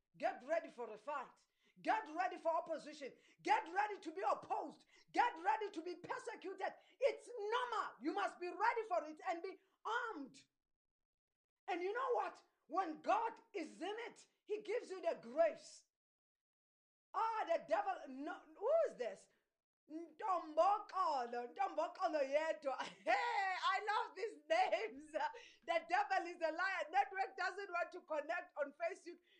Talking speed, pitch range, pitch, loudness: 145 wpm, 320-405 Hz, 360 Hz, -41 LUFS